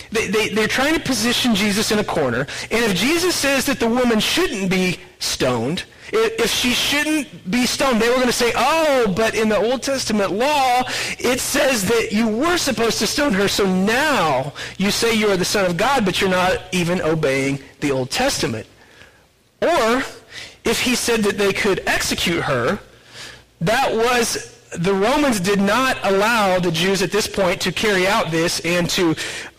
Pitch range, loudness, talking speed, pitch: 195-255 Hz, -18 LUFS, 185 wpm, 220 Hz